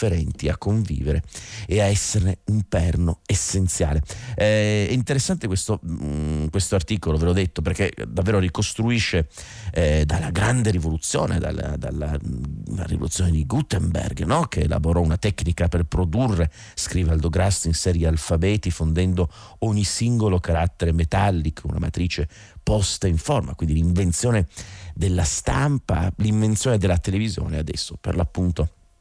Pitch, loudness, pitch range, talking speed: 90 Hz, -22 LUFS, 85-105 Hz, 125 wpm